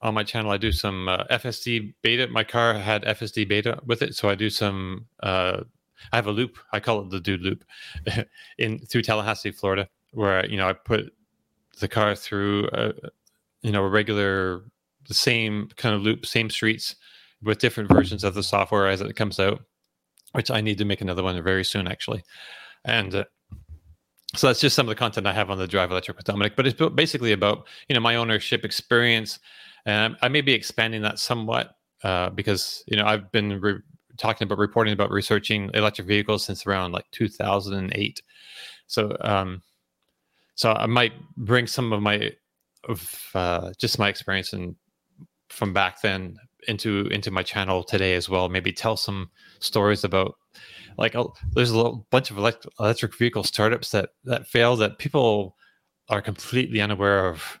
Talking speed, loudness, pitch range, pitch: 185 wpm, -24 LUFS, 100-115 Hz, 105 Hz